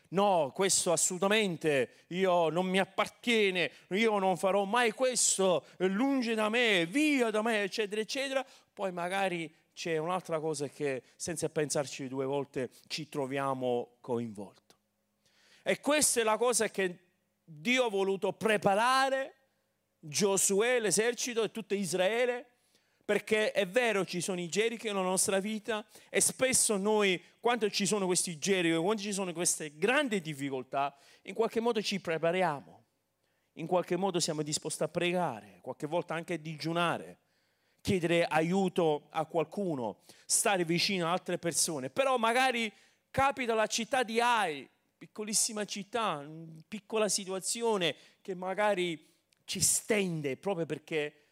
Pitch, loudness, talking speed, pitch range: 190 Hz, -31 LUFS, 135 wpm, 165-215 Hz